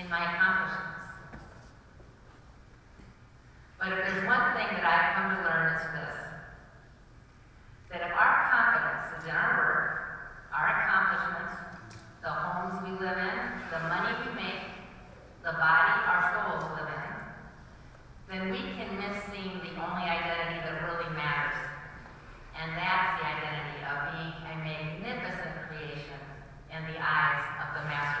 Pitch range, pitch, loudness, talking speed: 150-185 Hz, 165 Hz, -30 LUFS, 140 wpm